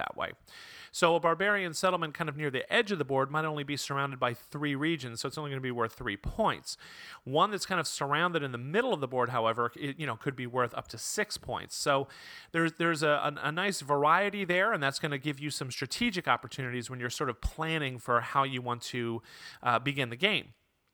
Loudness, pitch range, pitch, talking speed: -31 LUFS, 130-165 Hz, 145 Hz, 240 wpm